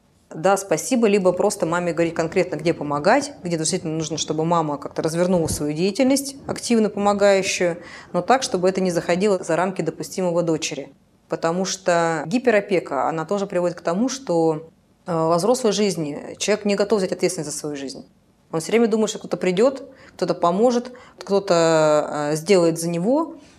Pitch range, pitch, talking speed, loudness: 165-205 Hz, 180 Hz, 160 wpm, -21 LUFS